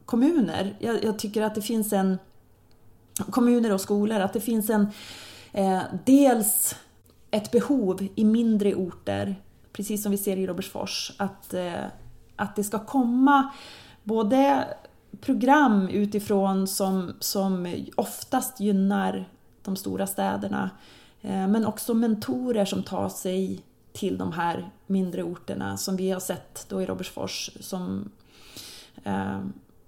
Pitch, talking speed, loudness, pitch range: 195 Hz, 130 wpm, -26 LUFS, 175-225 Hz